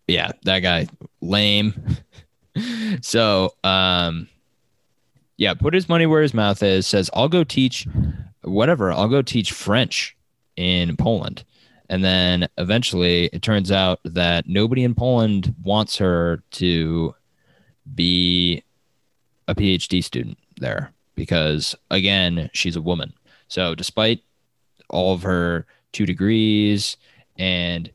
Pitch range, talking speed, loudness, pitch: 90-110 Hz, 120 wpm, -20 LUFS, 95 Hz